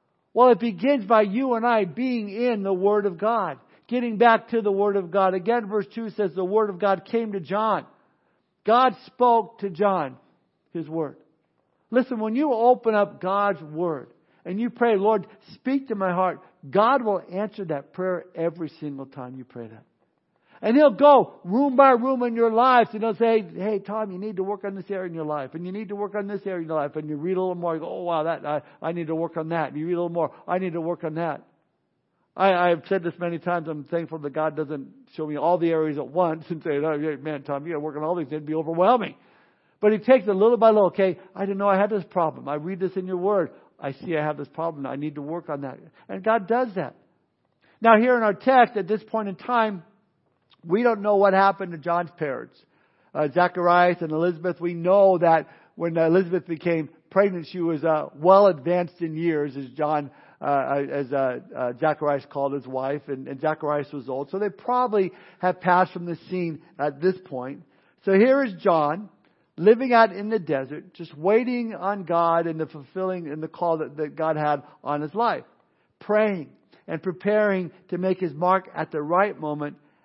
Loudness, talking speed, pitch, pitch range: -23 LUFS, 225 wpm, 180 Hz, 160-210 Hz